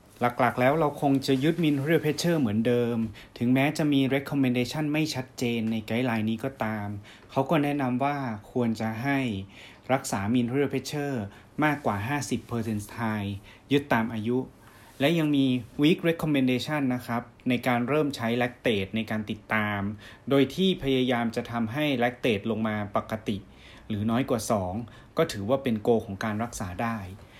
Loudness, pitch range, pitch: -27 LUFS, 110-140 Hz, 120 Hz